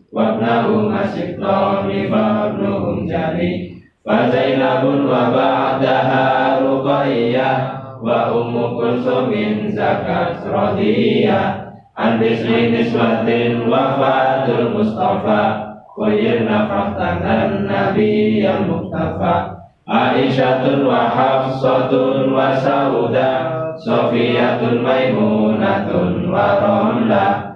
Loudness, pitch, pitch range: -16 LUFS, 130 Hz, 120-140 Hz